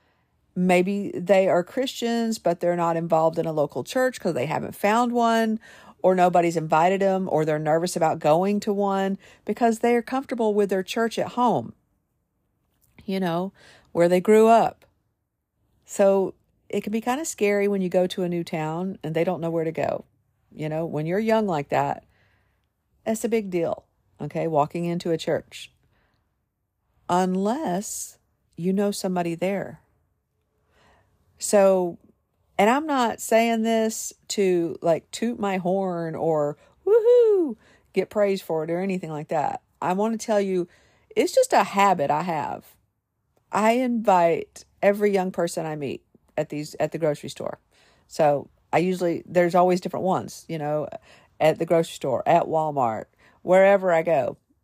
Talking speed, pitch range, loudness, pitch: 165 wpm, 160-210 Hz, -23 LUFS, 180 Hz